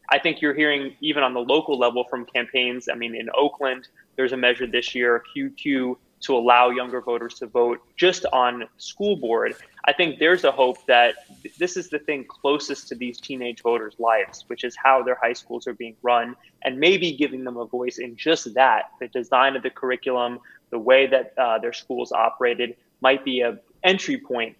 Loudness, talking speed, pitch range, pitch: -22 LUFS, 200 wpm, 120-140 Hz, 125 Hz